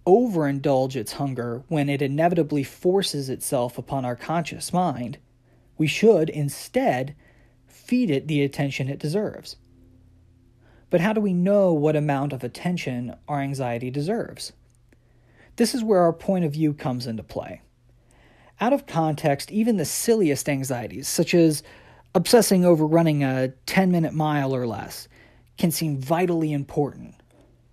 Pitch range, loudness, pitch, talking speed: 125-170 Hz, -23 LUFS, 145 Hz, 140 wpm